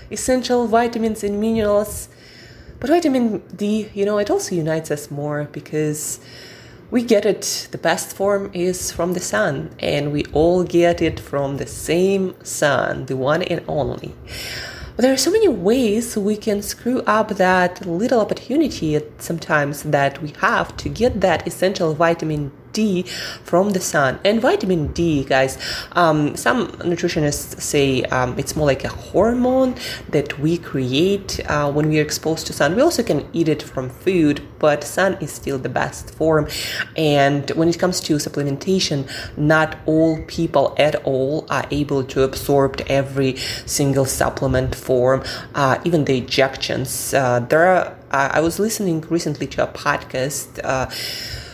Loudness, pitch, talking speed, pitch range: -19 LUFS, 155 Hz, 160 wpm, 140-190 Hz